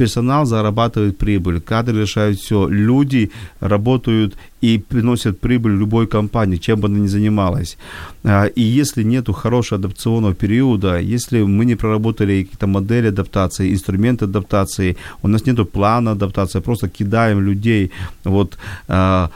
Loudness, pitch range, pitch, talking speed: -17 LUFS, 100-115 Hz, 105 Hz, 130 wpm